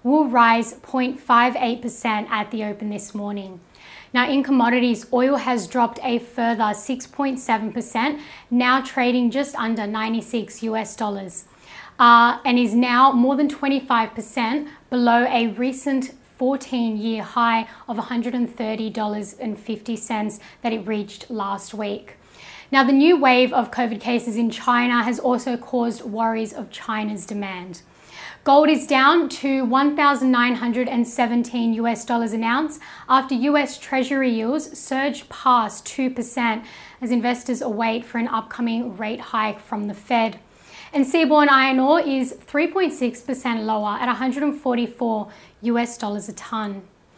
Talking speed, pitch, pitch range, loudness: 125 wpm, 240 Hz, 225-260 Hz, -21 LUFS